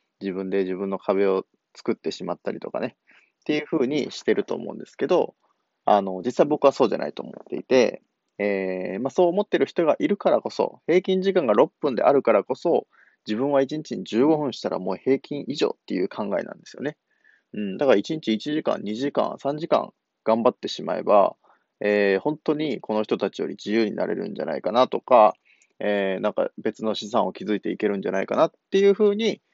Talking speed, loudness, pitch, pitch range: 380 characters per minute, -24 LUFS, 115 Hz, 100-155 Hz